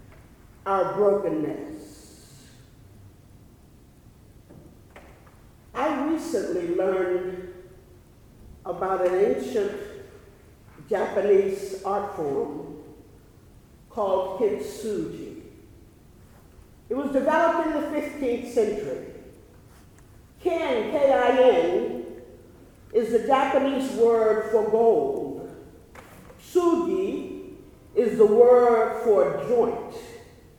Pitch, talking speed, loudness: 230 Hz, 65 wpm, -23 LUFS